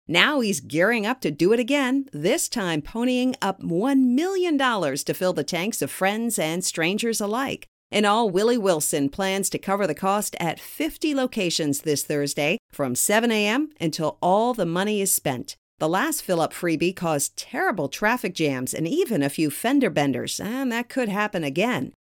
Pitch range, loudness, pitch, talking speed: 160-240 Hz, -23 LUFS, 195 Hz, 180 wpm